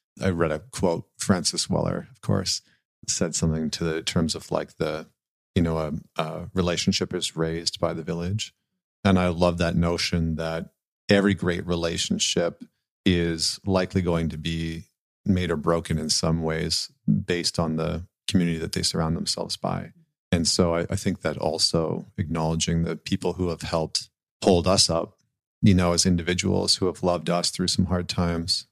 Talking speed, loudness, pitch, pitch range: 175 wpm, -25 LUFS, 85 Hz, 80-95 Hz